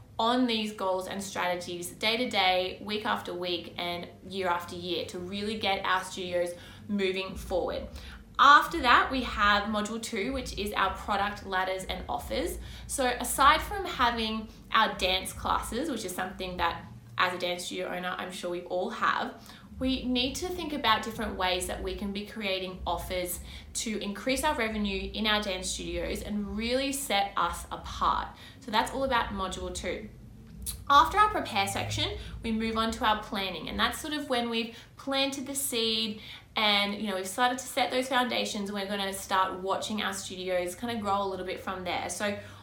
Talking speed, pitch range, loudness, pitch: 185 wpm, 185-235 Hz, -29 LUFS, 205 Hz